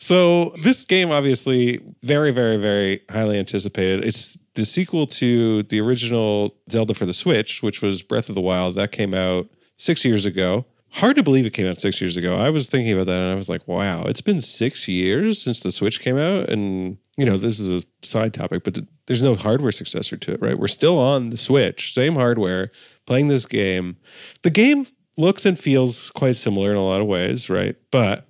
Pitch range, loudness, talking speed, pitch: 100-135 Hz, -20 LUFS, 210 wpm, 115 Hz